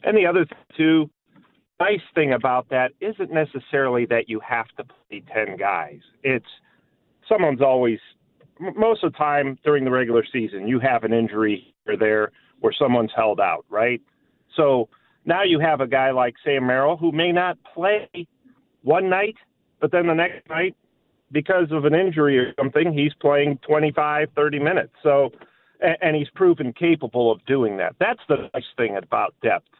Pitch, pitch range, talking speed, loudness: 145 Hz, 130-165 Hz, 170 wpm, -21 LUFS